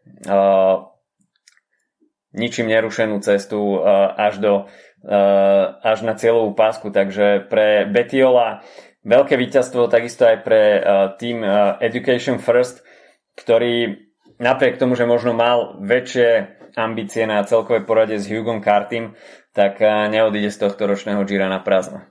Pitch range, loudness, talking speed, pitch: 100-115 Hz, -17 LUFS, 130 wpm, 110 Hz